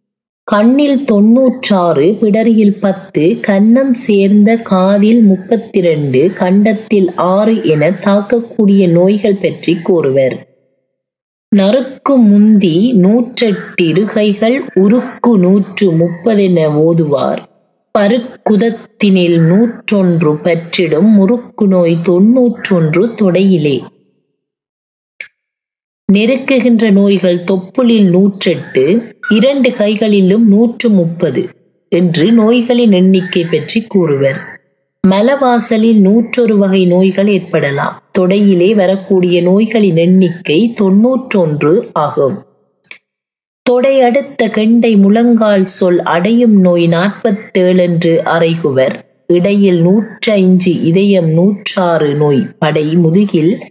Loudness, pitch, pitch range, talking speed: -10 LUFS, 195 Hz, 175-225 Hz, 80 wpm